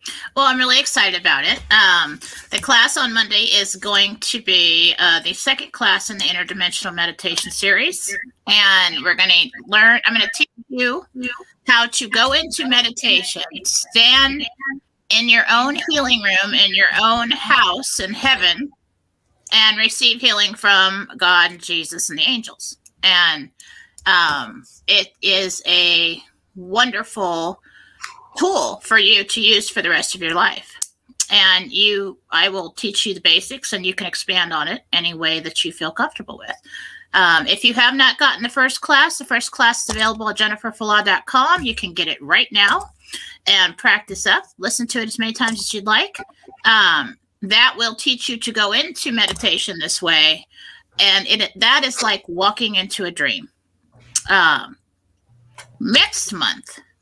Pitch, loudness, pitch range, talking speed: 220 Hz, -15 LUFS, 185-255 Hz, 165 wpm